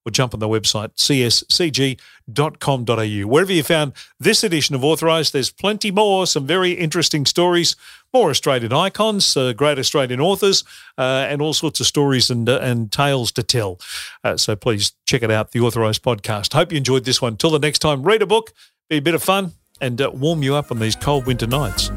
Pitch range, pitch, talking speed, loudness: 120-160 Hz, 140 Hz, 205 wpm, -17 LUFS